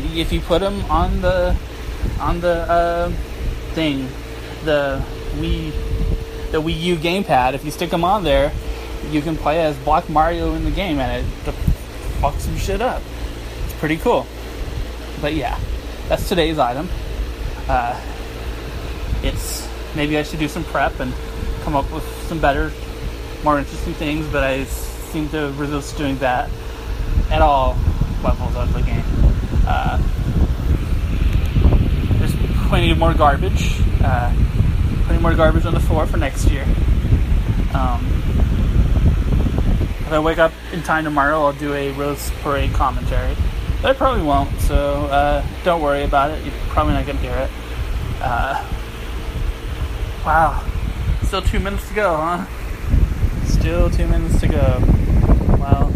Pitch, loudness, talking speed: 135 Hz, -20 LUFS, 145 wpm